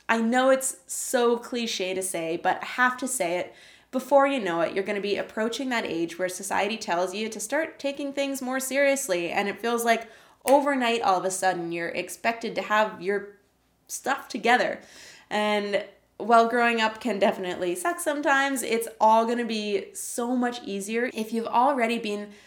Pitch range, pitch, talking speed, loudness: 195-255 Hz, 225 Hz, 185 wpm, -25 LUFS